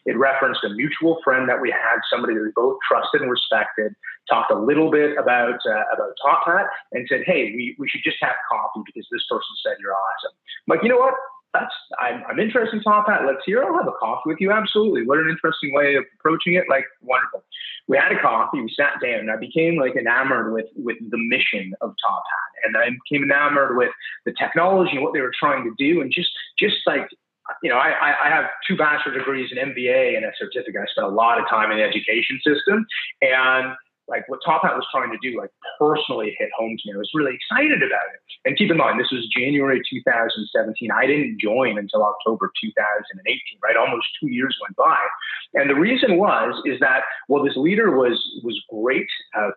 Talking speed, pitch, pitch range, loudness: 230 wpm, 150 Hz, 130-215 Hz, -20 LUFS